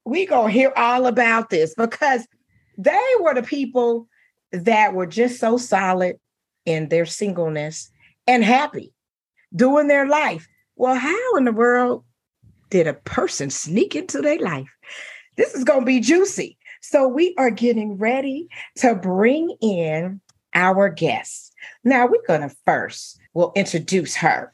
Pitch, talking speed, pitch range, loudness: 230 Hz, 150 wpm, 175-265 Hz, -19 LUFS